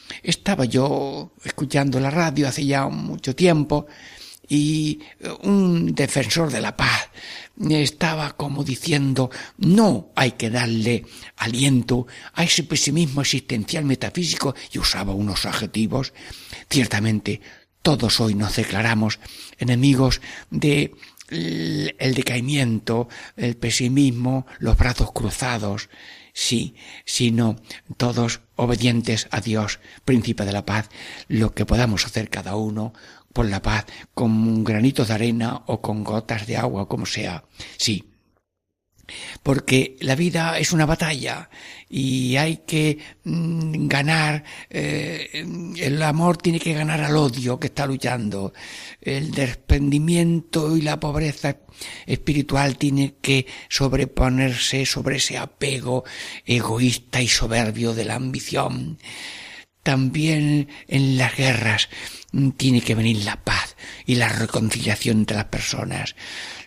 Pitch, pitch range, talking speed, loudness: 130 Hz, 115-145 Hz, 120 wpm, -22 LUFS